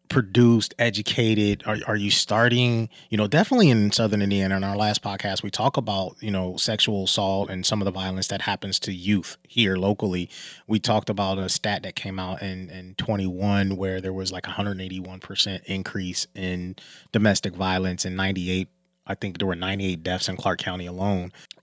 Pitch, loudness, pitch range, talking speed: 100 Hz, -24 LUFS, 95-105 Hz, 185 wpm